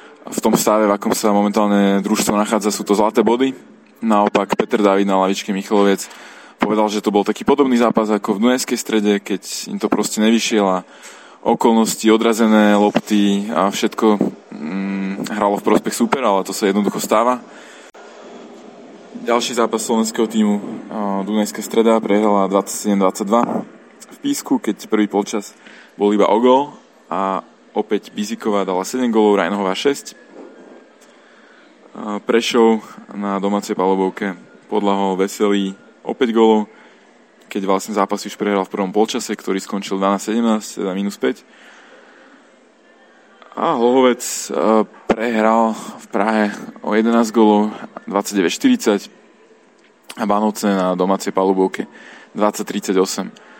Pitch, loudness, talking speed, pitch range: 105 Hz, -17 LUFS, 125 wpm, 100-110 Hz